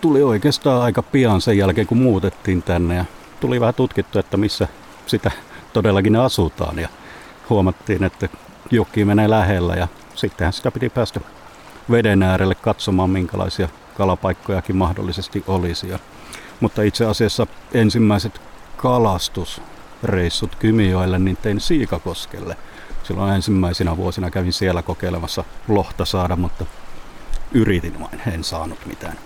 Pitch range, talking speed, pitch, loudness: 90-110 Hz, 120 wpm, 95 Hz, -19 LUFS